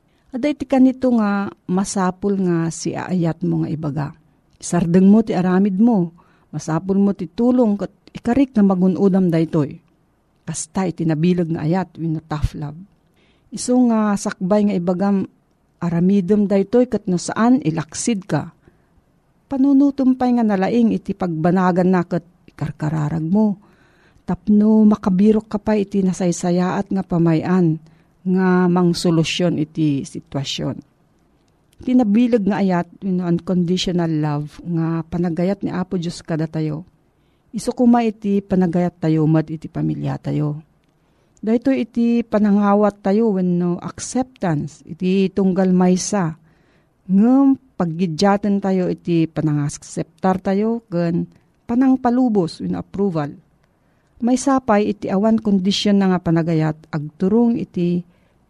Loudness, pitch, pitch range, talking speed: -18 LUFS, 185 Hz, 165-210 Hz, 120 wpm